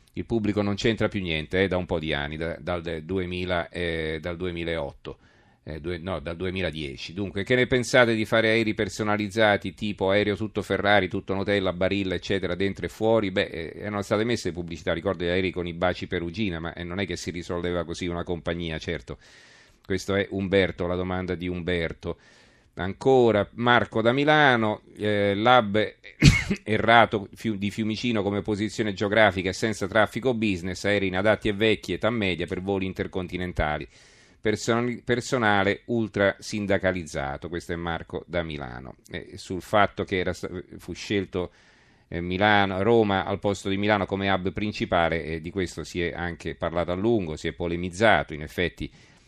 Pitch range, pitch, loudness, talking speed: 85-105 Hz, 95 Hz, -25 LUFS, 170 wpm